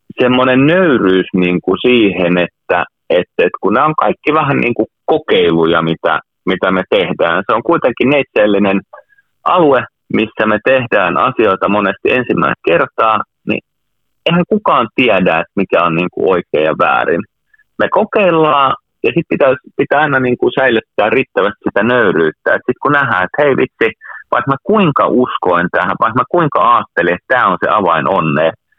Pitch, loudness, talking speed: 125 Hz, -12 LUFS, 165 wpm